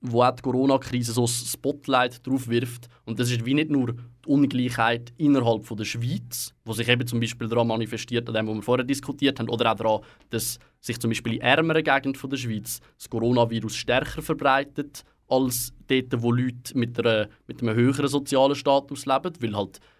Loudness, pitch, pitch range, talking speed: -25 LUFS, 120 Hz, 115-135 Hz, 190 wpm